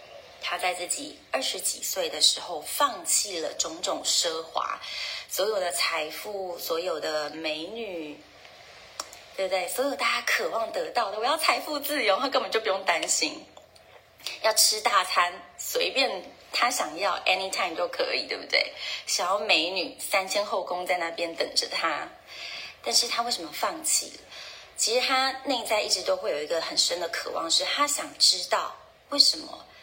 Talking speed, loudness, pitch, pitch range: 250 characters per minute, -26 LUFS, 230 Hz, 180-290 Hz